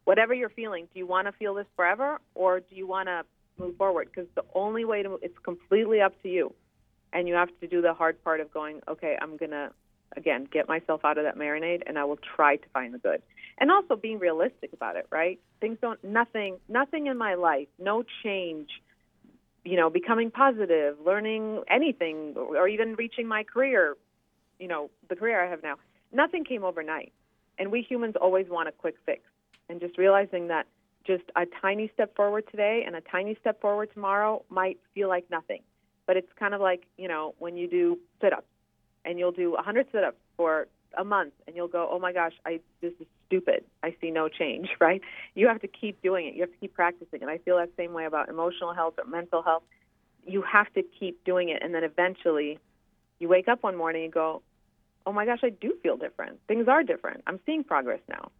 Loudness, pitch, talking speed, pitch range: -28 LUFS, 185 Hz, 220 wpm, 165-215 Hz